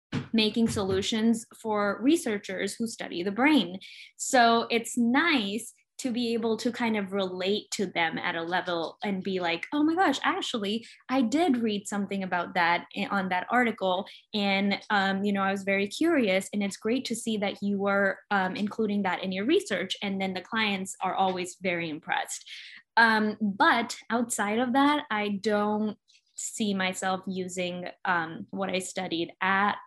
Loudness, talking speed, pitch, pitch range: -27 LUFS, 170 wpm, 205 Hz, 190-230 Hz